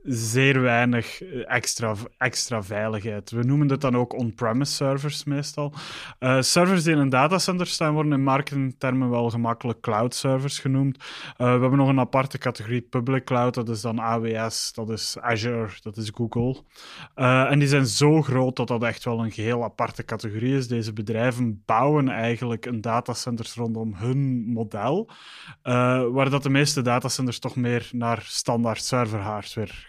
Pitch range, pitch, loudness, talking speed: 115-135 Hz, 125 Hz, -24 LUFS, 165 wpm